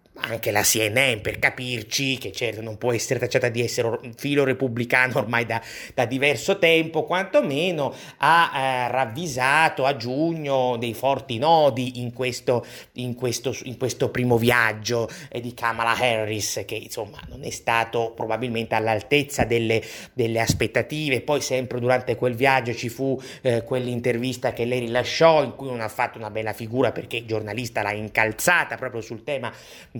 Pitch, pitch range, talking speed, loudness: 125 Hz, 115-135 Hz, 160 wpm, -23 LUFS